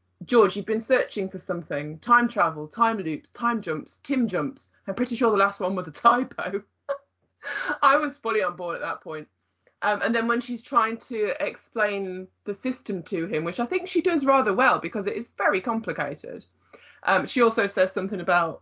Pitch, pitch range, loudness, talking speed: 220 Hz, 185-240 Hz, -25 LUFS, 195 wpm